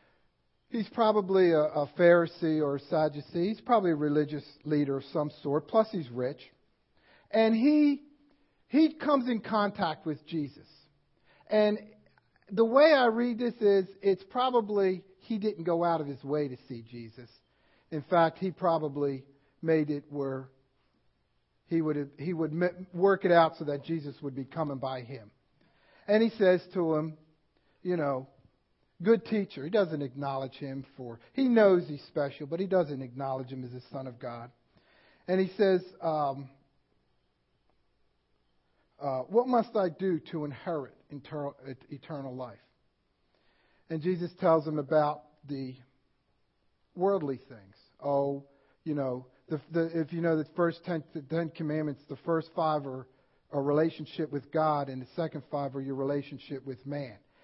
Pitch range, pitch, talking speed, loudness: 135-180 Hz, 155 Hz, 155 wpm, -30 LUFS